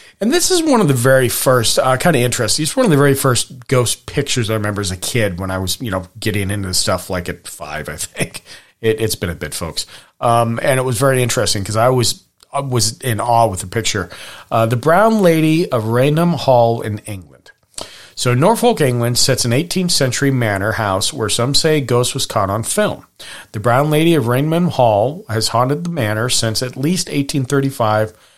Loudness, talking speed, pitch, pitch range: -16 LUFS, 215 wpm, 125 Hz, 110-140 Hz